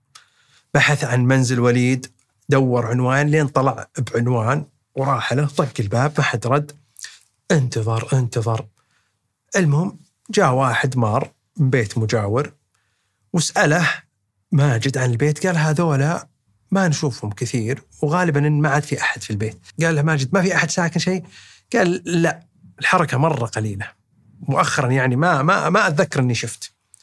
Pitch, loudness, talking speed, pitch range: 135 Hz, -19 LUFS, 140 wpm, 120-155 Hz